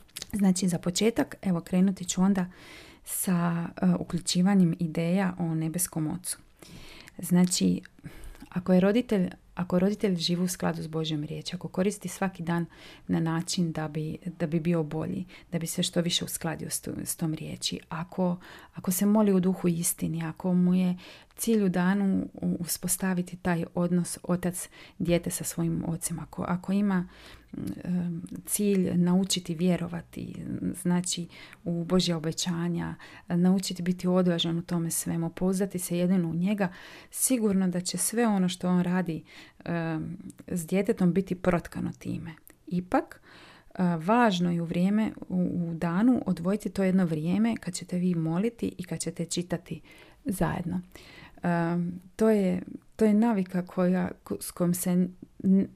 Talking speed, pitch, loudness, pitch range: 150 wpm, 180 Hz, -28 LUFS, 170-190 Hz